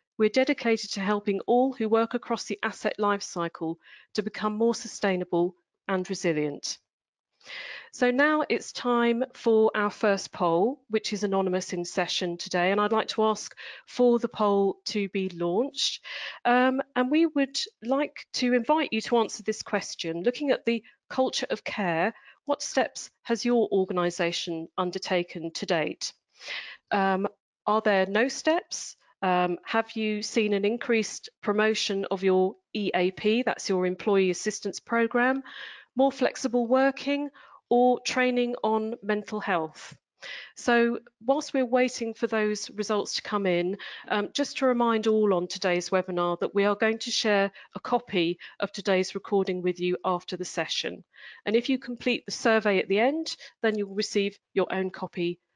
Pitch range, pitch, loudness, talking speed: 190-245 Hz, 215 Hz, -27 LUFS, 155 wpm